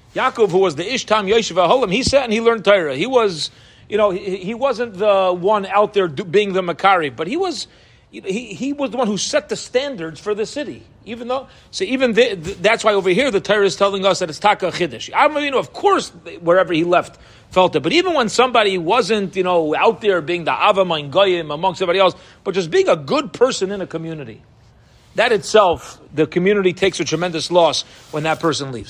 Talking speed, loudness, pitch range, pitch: 220 wpm, -17 LUFS, 175-225 Hz, 195 Hz